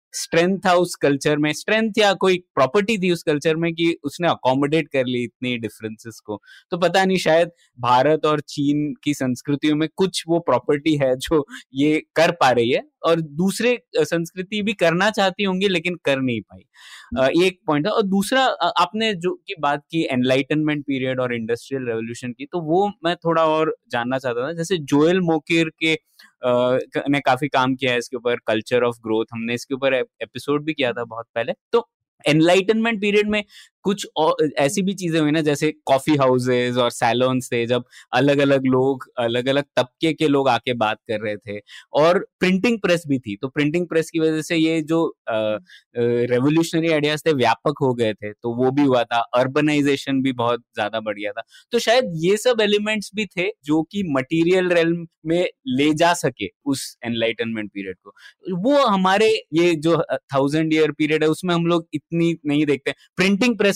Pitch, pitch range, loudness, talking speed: 150 Hz, 125-175 Hz, -20 LUFS, 185 wpm